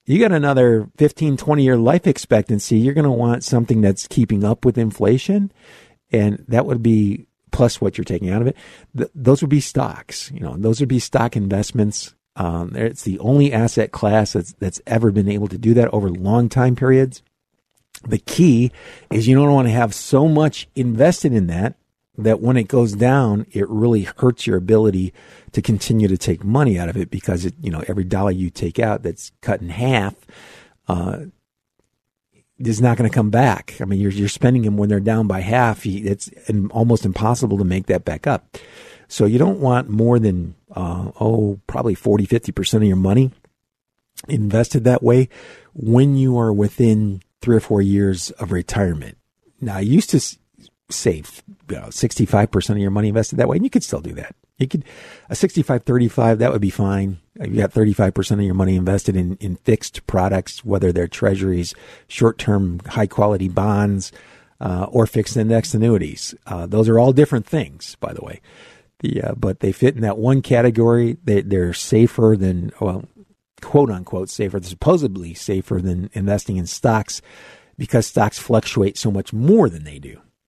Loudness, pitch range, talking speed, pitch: -18 LUFS, 100-125 Hz, 185 wpm, 110 Hz